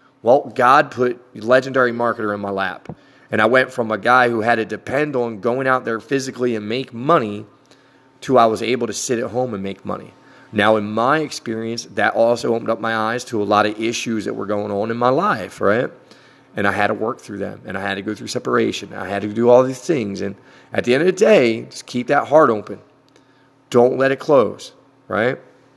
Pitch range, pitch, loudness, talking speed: 105-130 Hz, 120 Hz, -18 LUFS, 230 wpm